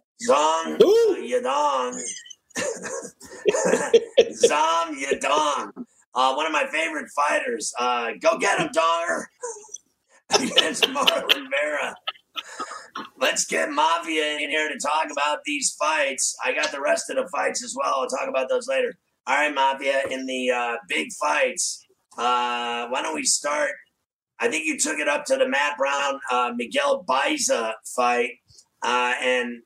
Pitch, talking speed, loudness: 260 Hz, 145 wpm, -23 LUFS